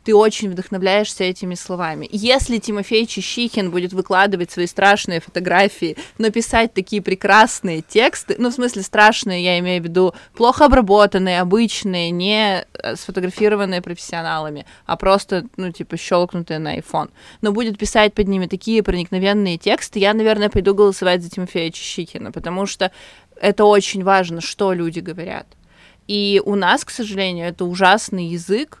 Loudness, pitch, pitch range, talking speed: -17 LUFS, 195 Hz, 180-210 Hz, 145 wpm